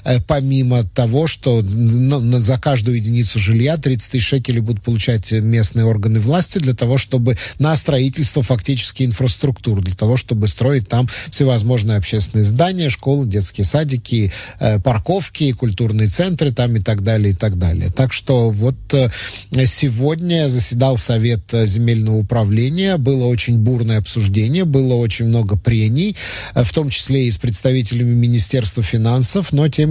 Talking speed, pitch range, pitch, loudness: 140 wpm, 110-135 Hz, 120 Hz, -16 LUFS